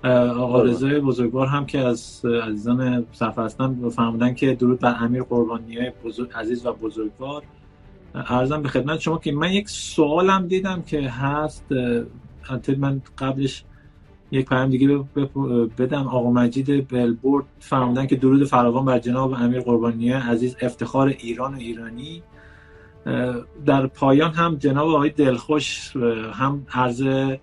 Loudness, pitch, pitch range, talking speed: -21 LUFS, 130 Hz, 120-140 Hz, 130 wpm